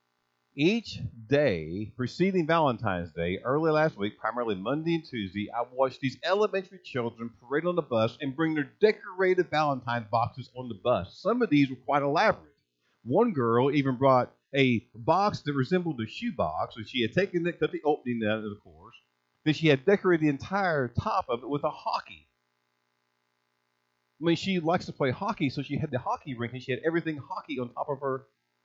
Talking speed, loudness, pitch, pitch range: 195 wpm, -28 LUFS, 130 Hz, 110-160 Hz